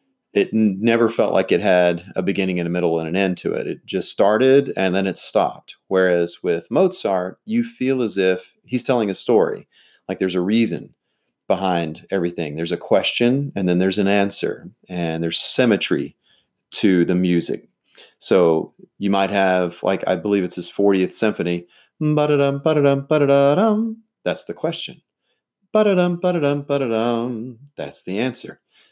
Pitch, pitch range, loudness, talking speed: 100 Hz, 90-140 Hz, -19 LUFS, 145 wpm